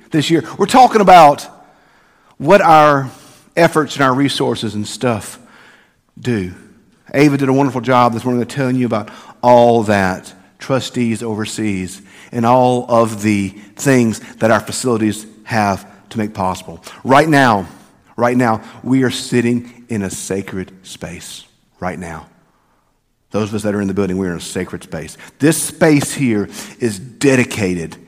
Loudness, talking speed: -15 LUFS, 150 wpm